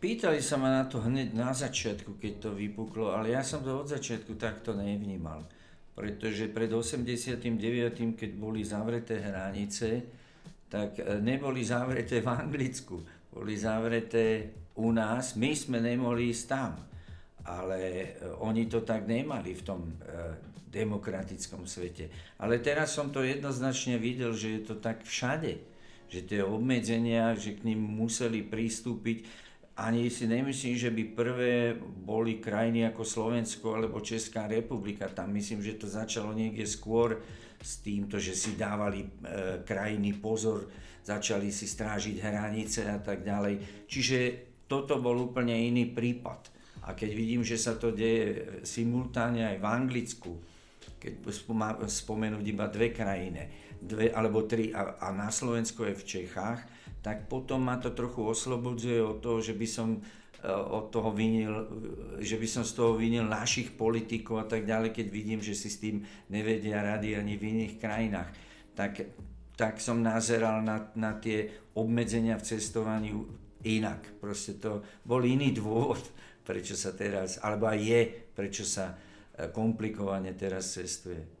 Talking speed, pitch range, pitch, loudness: 145 wpm, 105-115 Hz, 110 Hz, -33 LUFS